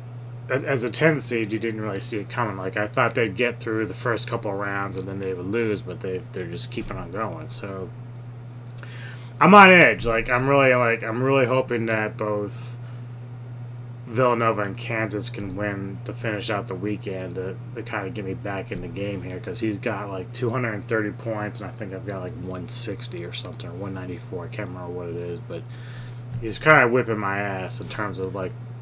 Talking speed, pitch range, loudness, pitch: 210 wpm, 105-120 Hz, -23 LUFS, 115 Hz